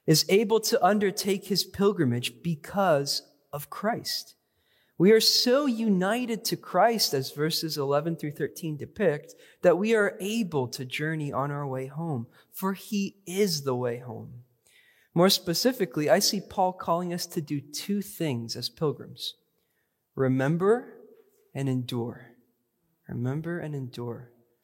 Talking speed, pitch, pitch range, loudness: 135 wpm, 165 Hz, 135-200 Hz, -27 LUFS